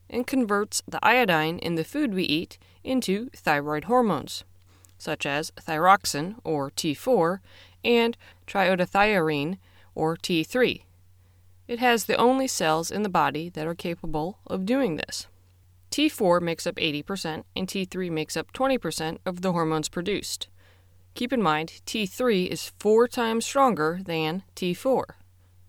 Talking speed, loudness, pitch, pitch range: 135 wpm, -25 LUFS, 165 Hz, 145-210 Hz